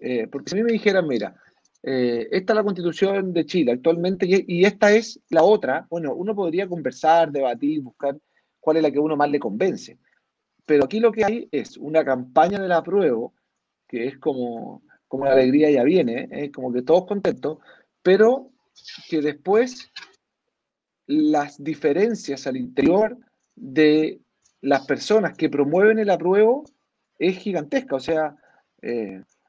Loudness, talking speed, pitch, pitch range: -21 LUFS, 165 wpm, 165 Hz, 145-205 Hz